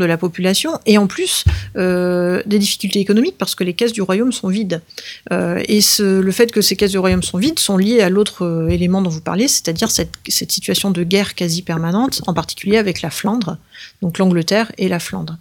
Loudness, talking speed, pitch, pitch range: -16 LUFS, 220 wpm, 190 Hz, 175-210 Hz